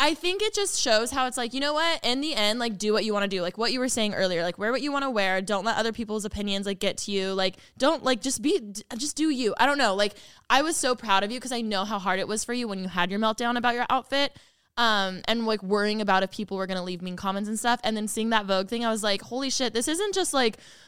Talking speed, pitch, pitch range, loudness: 310 wpm, 220 Hz, 200-255 Hz, -26 LUFS